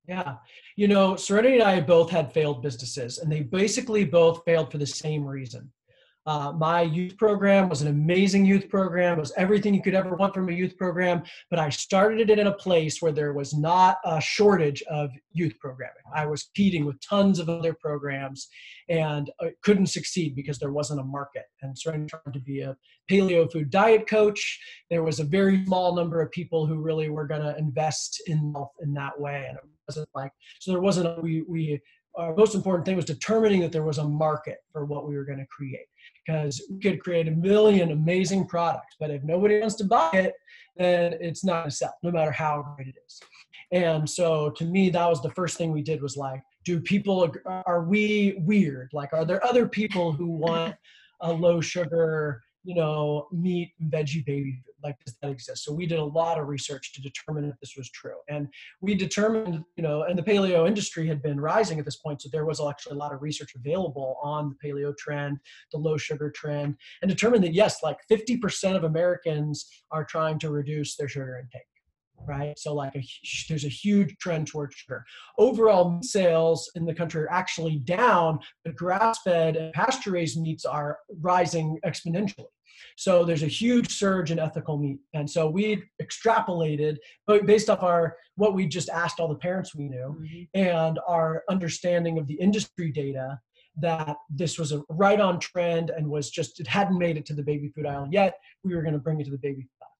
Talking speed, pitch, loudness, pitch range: 205 wpm, 165 Hz, -25 LUFS, 150-185 Hz